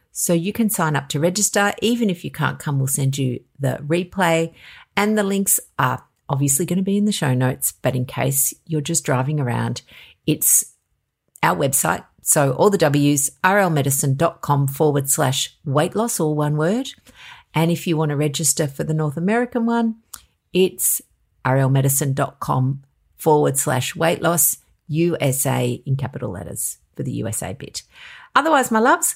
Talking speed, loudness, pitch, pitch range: 165 wpm, -19 LUFS, 155 Hz, 135-190 Hz